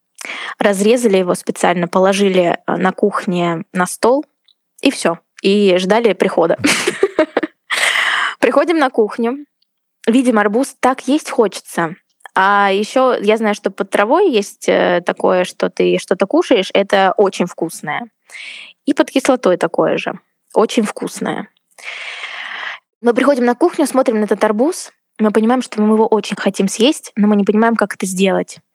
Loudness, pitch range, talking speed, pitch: -15 LUFS, 195-260 Hz, 140 wpm, 215 Hz